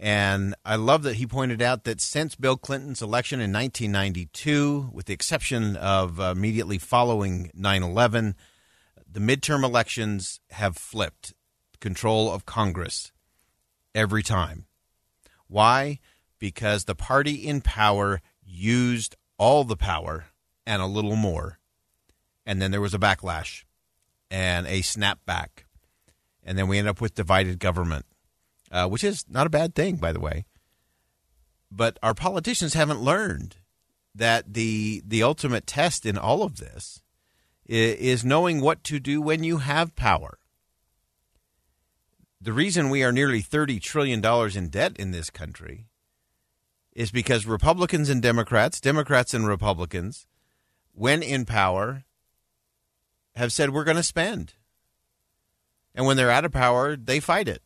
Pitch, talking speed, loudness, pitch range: 110 Hz, 140 wpm, -24 LUFS, 90-130 Hz